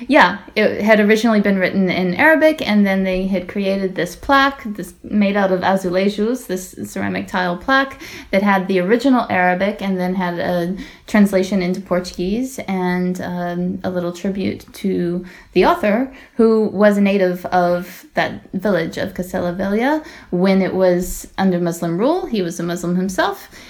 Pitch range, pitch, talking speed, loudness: 180-215 Hz, 190 Hz, 160 wpm, -17 LUFS